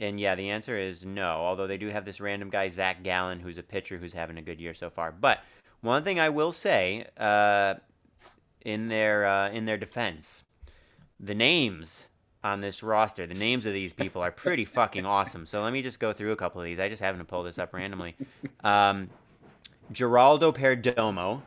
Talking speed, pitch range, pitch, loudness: 205 wpm, 90-110 Hz, 100 Hz, -28 LUFS